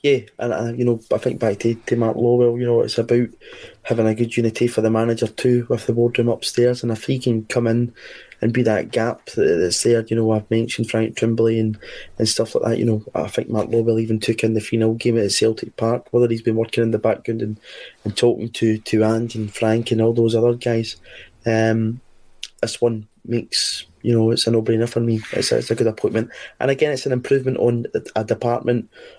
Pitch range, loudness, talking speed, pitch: 110-120 Hz, -20 LUFS, 230 wpm, 115 Hz